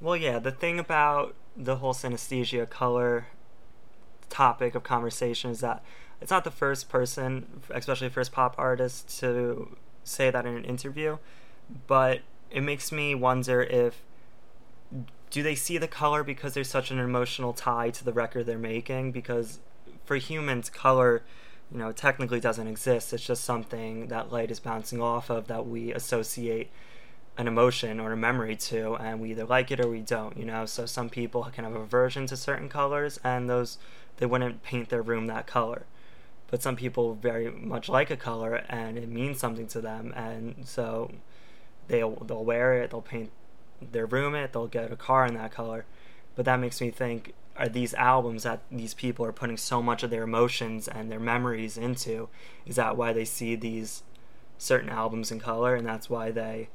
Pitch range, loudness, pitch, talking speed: 115-130 Hz, -29 LUFS, 120 Hz, 185 wpm